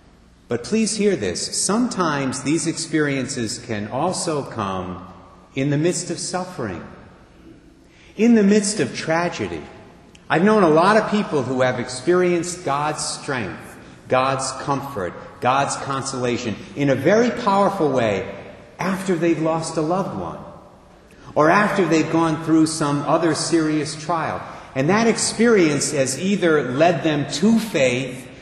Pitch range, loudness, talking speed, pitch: 130-180 Hz, -20 LUFS, 135 wpm, 160 Hz